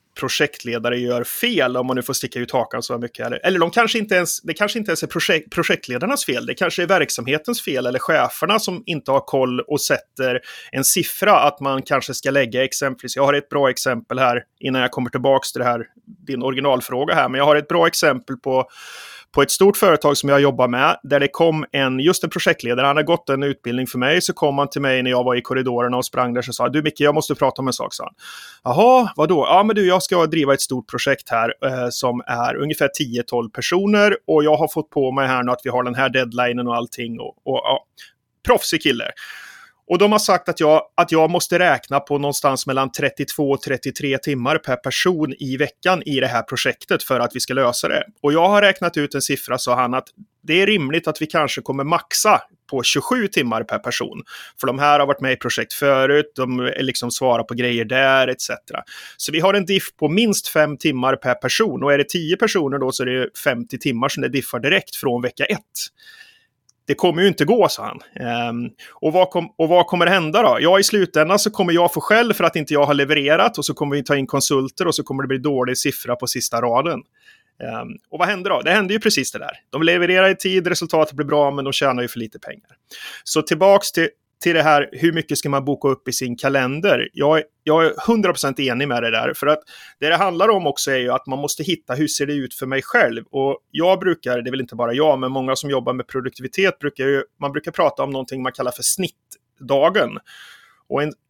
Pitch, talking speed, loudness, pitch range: 140 Hz, 235 wpm, -18 LUFS, 130-170 Hz